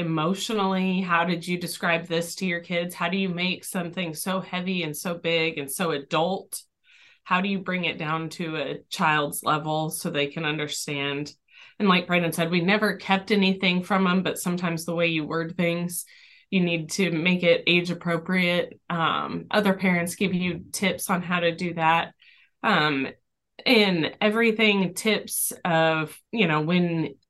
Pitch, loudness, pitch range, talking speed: 175 Hz, -24 LUFS, 165-190 Hz, 175 wpm